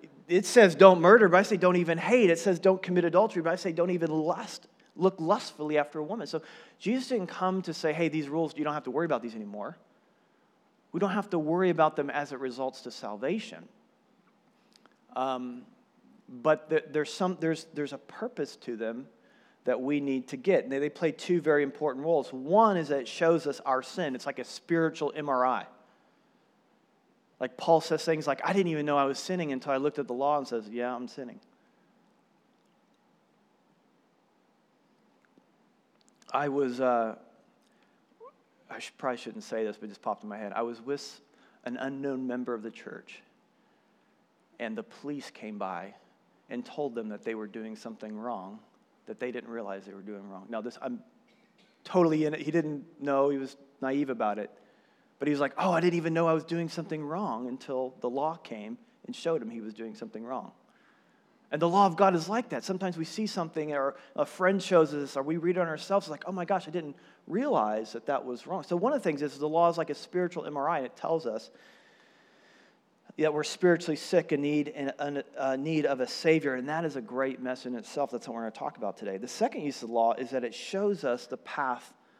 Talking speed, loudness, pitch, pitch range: 215 wpm, -29 LUFS, 150 Hz, 130-175 Hz